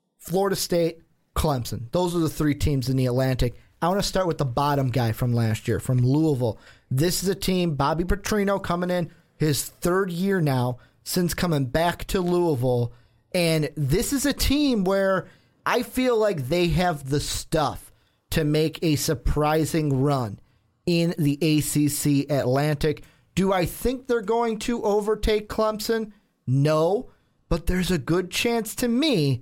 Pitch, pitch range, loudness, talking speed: 160 Hz, 140-190 Hz, -24 LUFS, 160 wpm